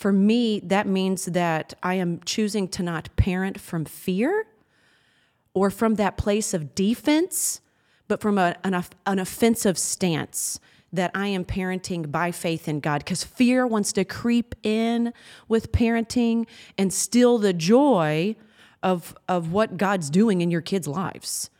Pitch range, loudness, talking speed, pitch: 180-220 Hz, -24 LUFS, 155 wpm, 195 Hz